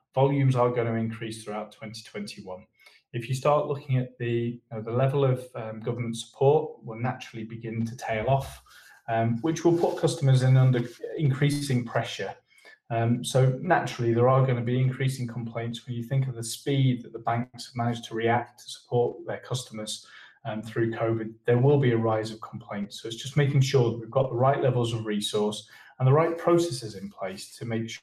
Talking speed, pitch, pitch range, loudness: 205 wpm, 120 Hz, 115-130 Hz, -27 LUFS